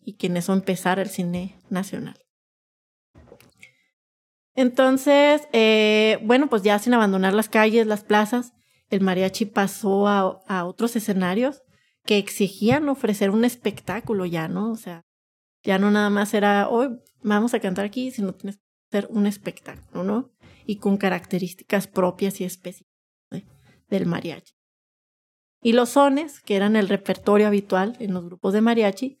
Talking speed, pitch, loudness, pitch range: 150 wpm, 205 Hz, -22 LUFS, 190-230 Hz